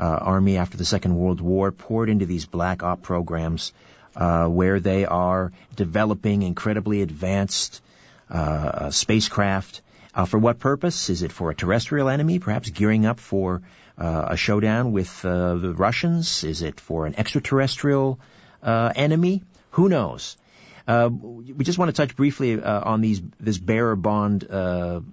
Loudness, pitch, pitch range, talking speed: -23 LUFS, 100 Hz, 90-115 Hz, 160 wpm